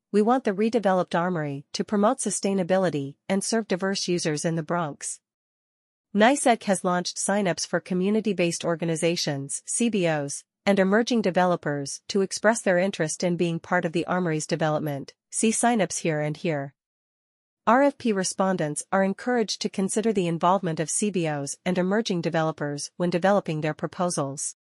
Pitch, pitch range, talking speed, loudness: 180 Hz, 160-200 Hz, 145 wpm, -25 LUFS